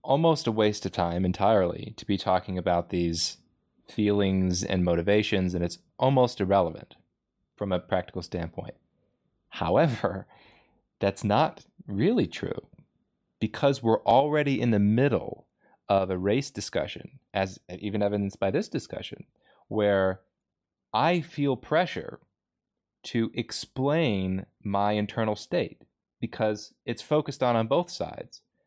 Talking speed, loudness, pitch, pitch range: 125 wpm, -27 LUFS, 105 Hz, 95-120 Hz